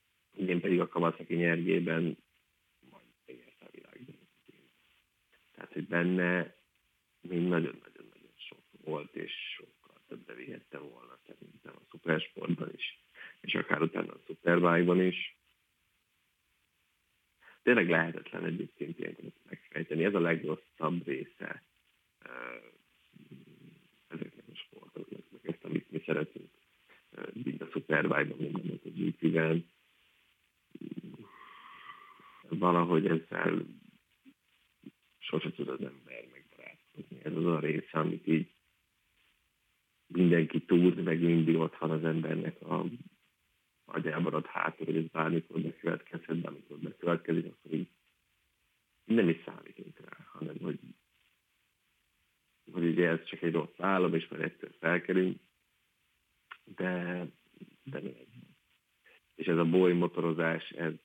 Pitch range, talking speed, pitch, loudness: 80-90 Hz, 110 wpm, 85 Hz, -32 LUFS